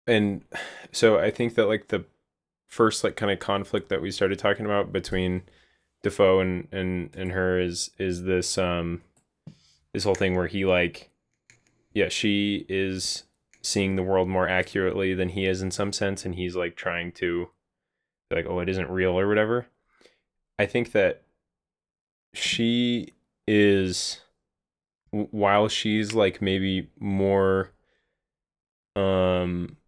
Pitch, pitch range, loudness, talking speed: 95 Hz, 90-100 Hz, -25 LUFS, 140 wpm